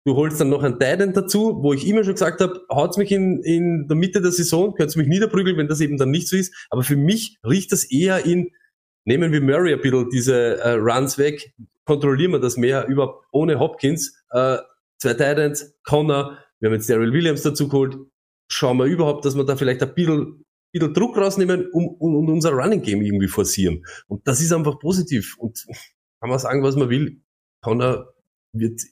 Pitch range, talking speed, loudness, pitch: 135-175 Hz, 205 wpm, -20 LUFS, 150 Hz